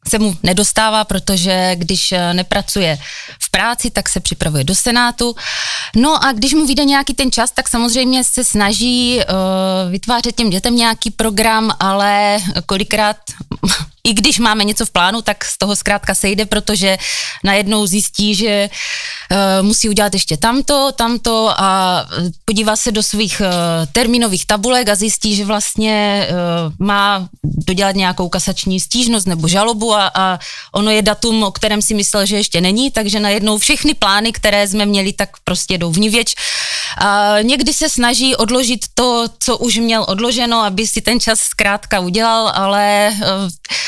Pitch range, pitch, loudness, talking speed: 195-230 Hz, 210 Hz, -13 LUFS, 155 wpm